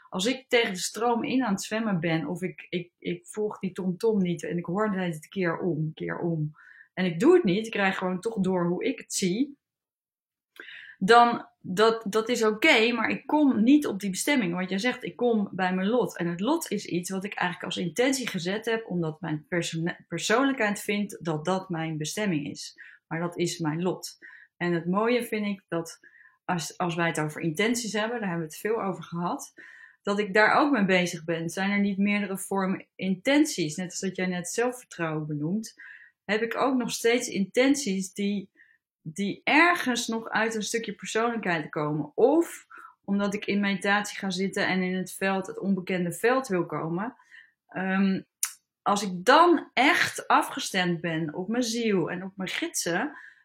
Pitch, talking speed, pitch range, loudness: 195 Hz, 195 wpm, 175-225 Hz, -27 LUFS